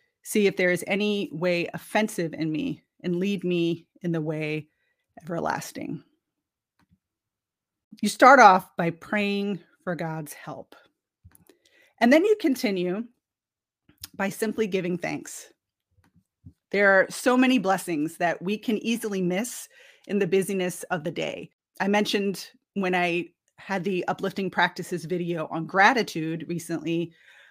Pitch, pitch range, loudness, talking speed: 180 Hz, 165-205 Hz, -25 LUFS, 130 wpm